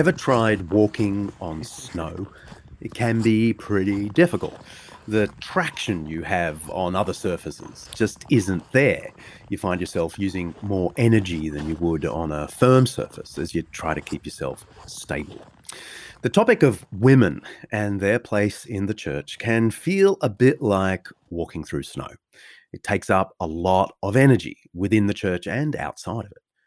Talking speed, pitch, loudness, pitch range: 160 wpm, 100 Hz, -22 LUFS, 90-115 Hz